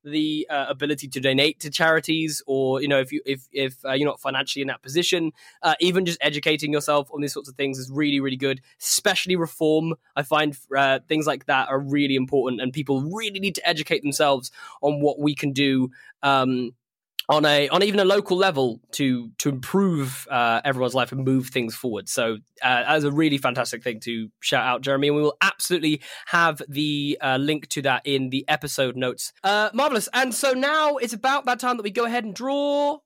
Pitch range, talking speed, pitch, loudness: 135-165 Hz, 210 wpm, 145 Hz, -23 LUFS